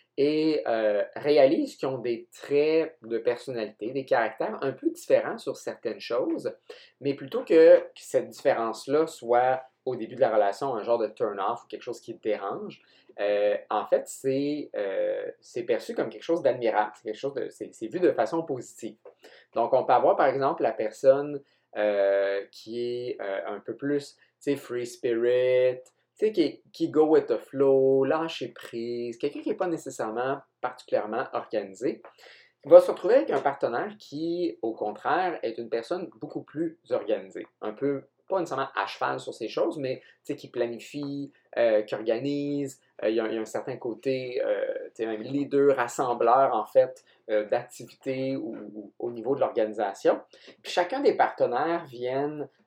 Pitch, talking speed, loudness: 140 Hz, 175 wpm, -27 LUFS